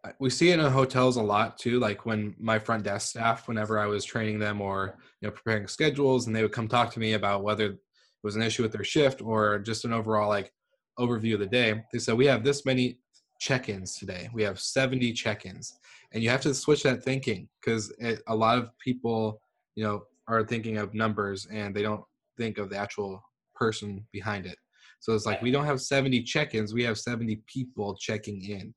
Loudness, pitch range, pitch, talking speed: -28 LUFS, 105-125 Hz, 110 Hz, 215 wpm